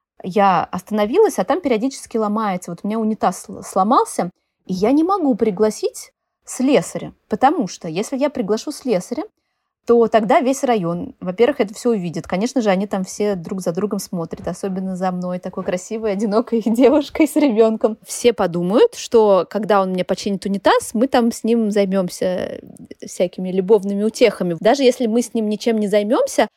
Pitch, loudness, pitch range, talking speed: 220 Hz, -18 LUFS, 195-245 Hz, 165 wpm